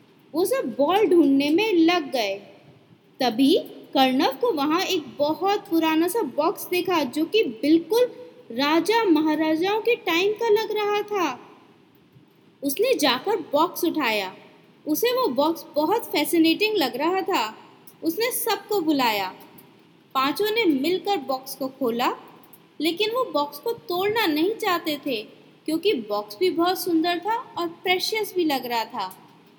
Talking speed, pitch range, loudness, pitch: 140 wpm, 295-415 Hz, -23 LUFS, 340 Hz